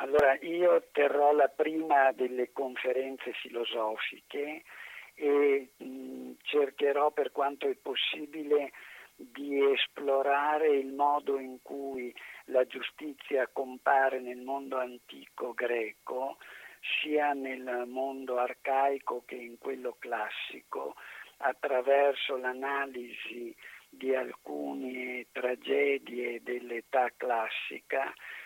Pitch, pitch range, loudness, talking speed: 135 Hz, 125-145 Hz, -31 LUFS, 90 wpm